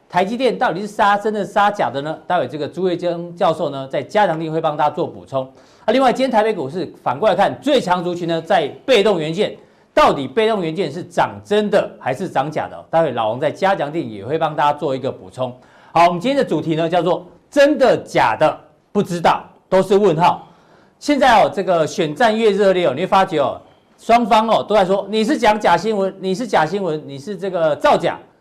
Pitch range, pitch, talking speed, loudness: 160-210 Hz, 185 Hz, 320 characters per minute, -17 LUFS